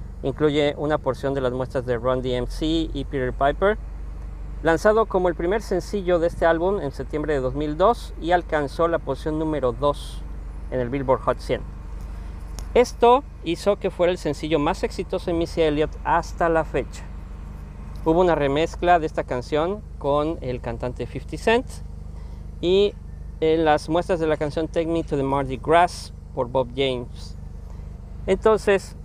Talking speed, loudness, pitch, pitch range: 160 wpm, -23 LUFS, 150 Hz, 125-170 Hz